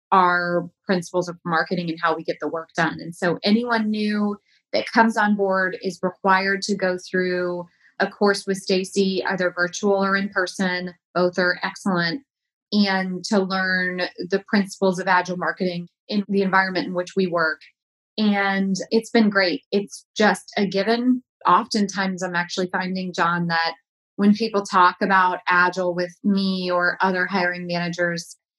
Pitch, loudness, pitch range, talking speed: 185 Hz, -22 LUFS, 175-200 Hz, 160 wpm